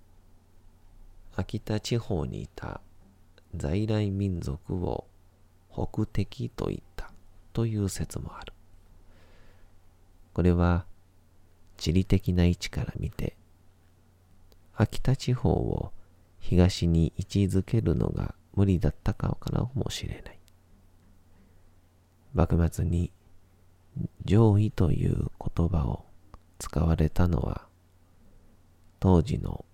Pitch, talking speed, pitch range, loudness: 90 Hz, 175 characters per minute, 85-95 Hz, -28 LUFS